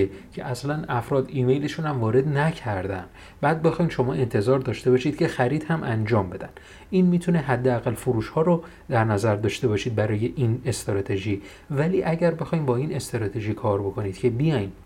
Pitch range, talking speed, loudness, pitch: 105-150 Hz, 165 wpm, -24 LUFS, 125 Hz